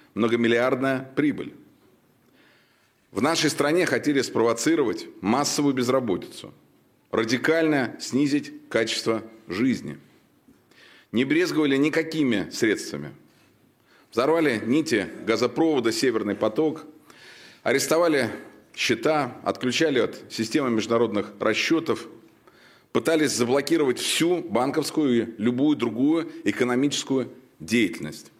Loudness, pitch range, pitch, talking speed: -24 LUFS, 120-165 Hz, 145 Hz, 80 wpm